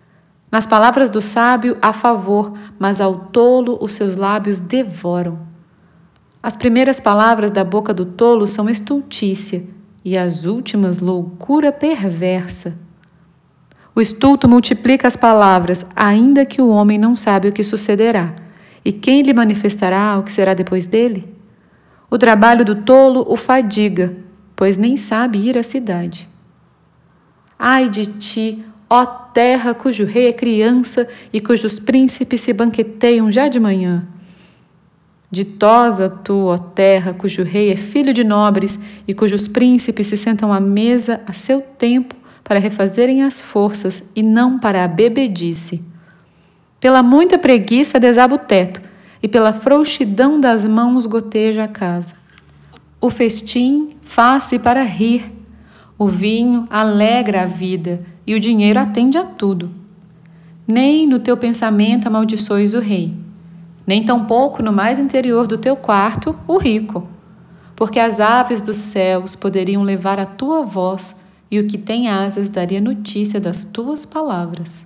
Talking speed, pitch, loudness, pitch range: 140 wpm, 215 Hz, -14 LUFS, 190-240 Hz